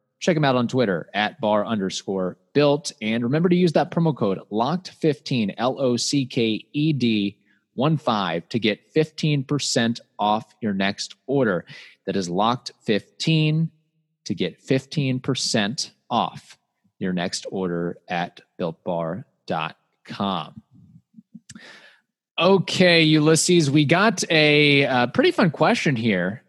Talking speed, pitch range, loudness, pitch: 110 wpm, 115-165 Hz, -22 LUFS, 145 Hz